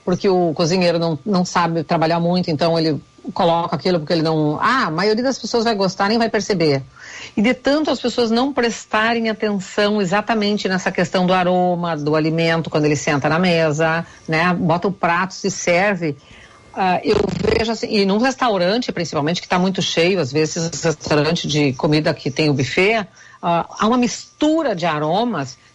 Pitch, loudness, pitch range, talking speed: 180 Hz, -18 LUFS, 160-210 Hz, 185 wpm